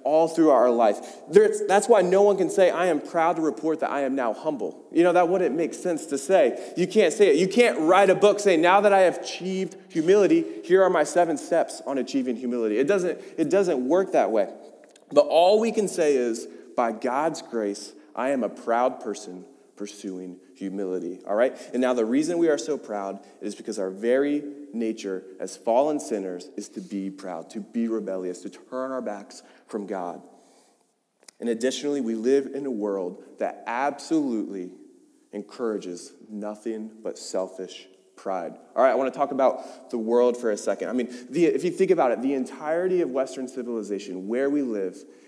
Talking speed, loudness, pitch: 195 wpm, -24 LUFS, 135 Hz